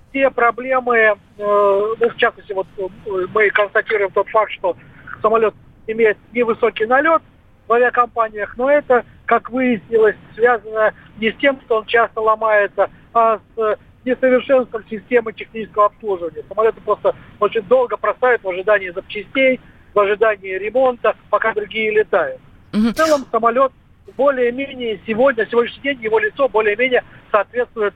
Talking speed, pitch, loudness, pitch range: 135 wpm, 220 Hz, -17 LUFS, 210-245 Hz